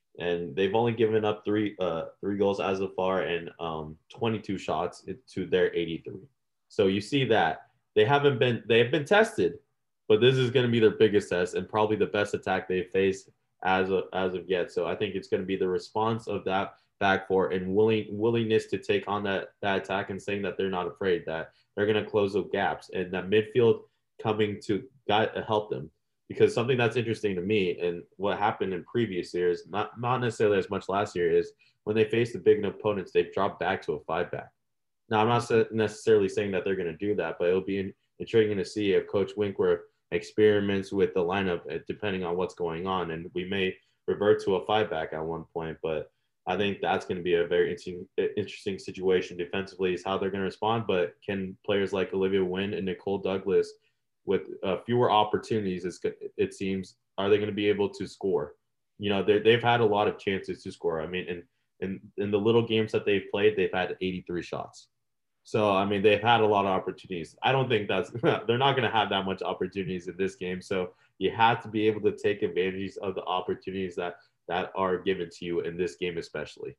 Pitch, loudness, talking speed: 110 Hz, -28 LUFS, 220 wpm